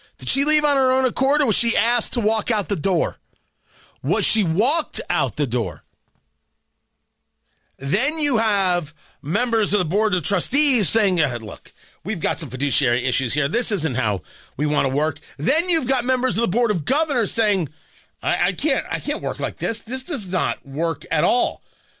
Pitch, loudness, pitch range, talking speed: 205 Hz, -21 LUFS, 150-245 Hz, 195 wpm